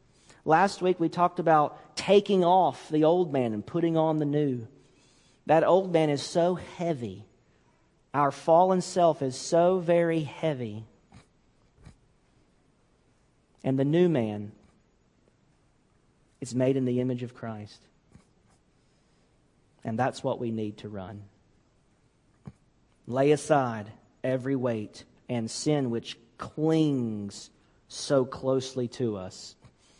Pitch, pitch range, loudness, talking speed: 135 Hz, 115-160 Hz, -27 LUFS, 115 wpm